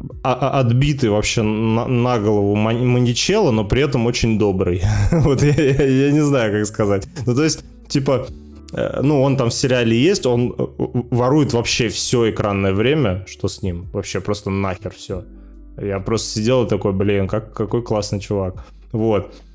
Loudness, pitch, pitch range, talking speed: -18 LUFS, 110 Hz, 100-130 Hz, 155 wpm